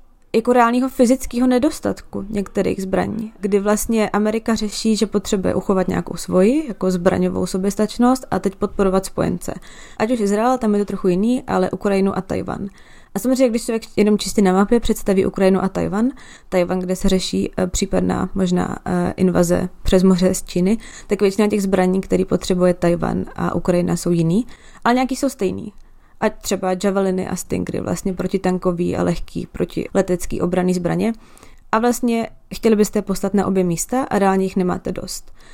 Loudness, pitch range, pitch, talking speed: -19 LUFS, 185-220 Hz, 195 Hz, 165 wpm